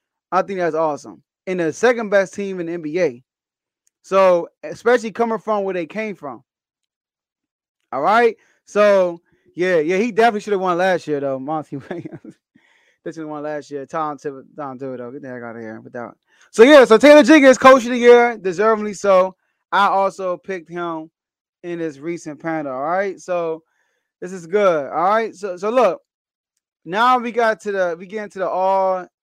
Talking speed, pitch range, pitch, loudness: 190 wpm, 160-210 Hz, 185 Hz, -17 LUFS